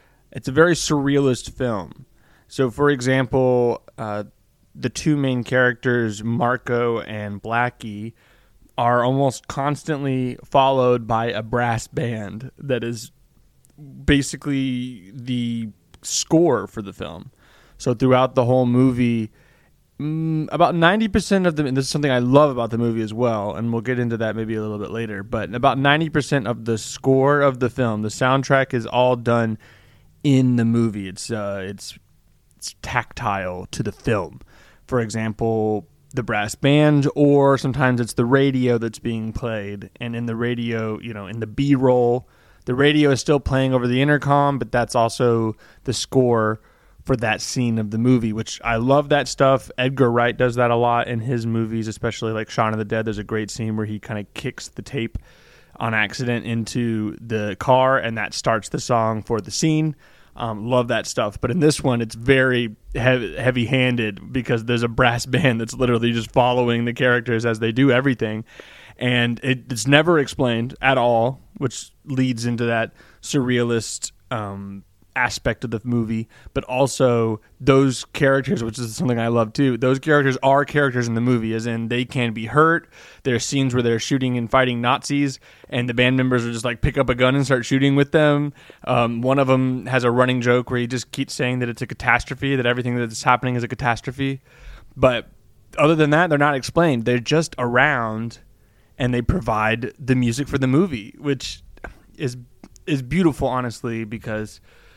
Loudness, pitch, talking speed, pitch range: -20 LUFS, 125 Hz, 180 wpm, 115-135 Hz